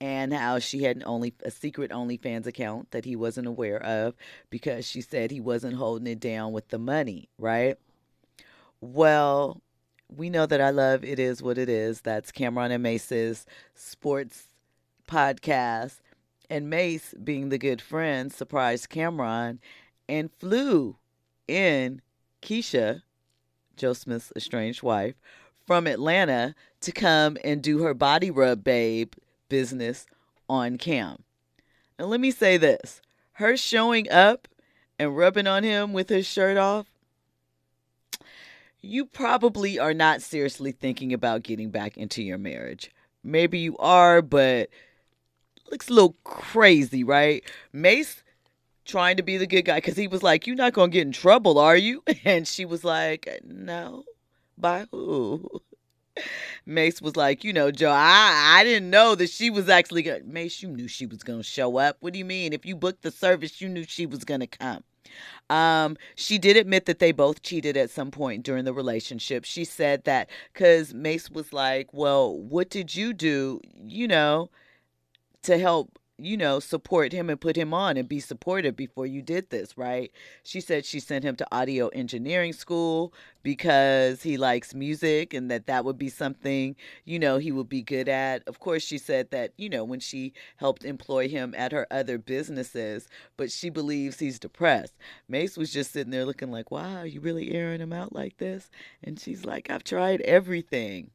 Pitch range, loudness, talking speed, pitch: 125-175 Hz, -24 LUFS, 170 wpm, 145 Hz